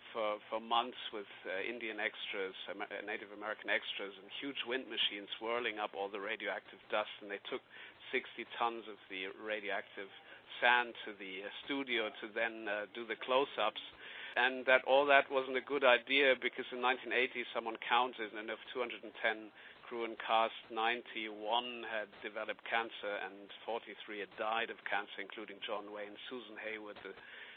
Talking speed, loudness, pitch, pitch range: 160 wpm, -37 LUFS, 115 Hz, 105-125 Hz